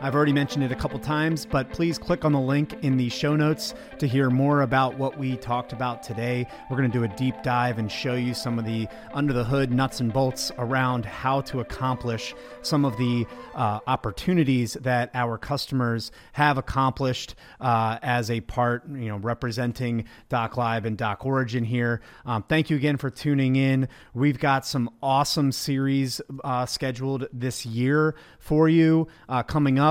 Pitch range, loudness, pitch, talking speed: 120-140 Hz, -25 LUFS, 130 Hz, 185 wpm